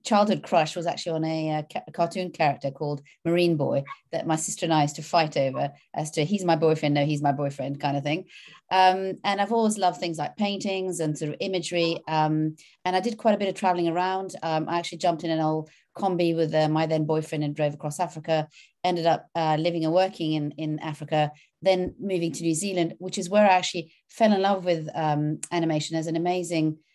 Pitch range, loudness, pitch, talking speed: 155-180 Hz, -26 LUFS, 165 Hz, 225 wpm